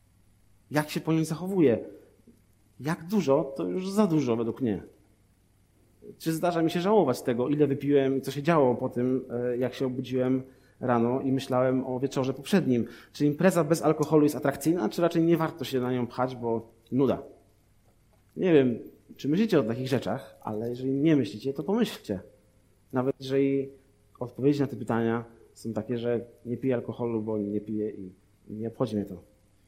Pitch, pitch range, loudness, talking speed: 125 Hz, 110-145 Hz, -28 LUFS, 170 wpm